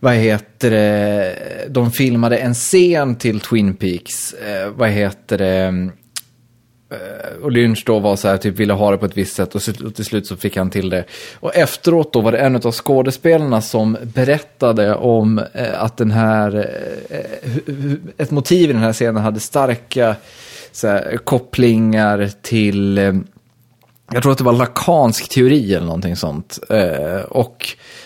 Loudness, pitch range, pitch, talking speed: -16 LUFS, 105-125 Hz, 115 Hz, 155 wpm